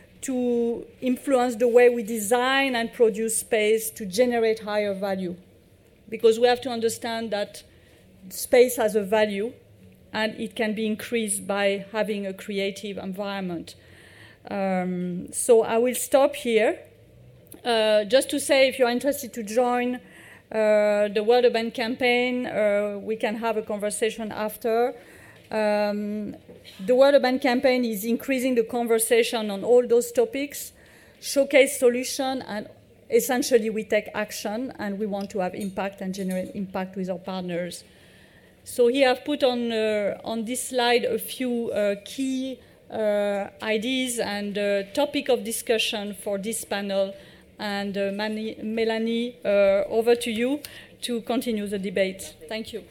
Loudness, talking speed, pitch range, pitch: -24 LUFS, 145 wpm, 205-245 Hz, 225 Hz